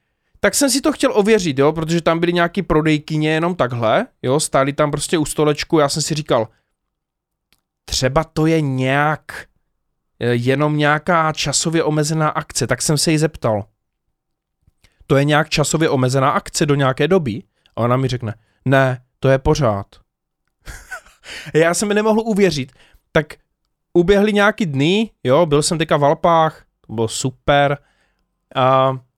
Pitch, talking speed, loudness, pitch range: 150 Hz, 150 wpm, -17 LUFS, 130-165 Hz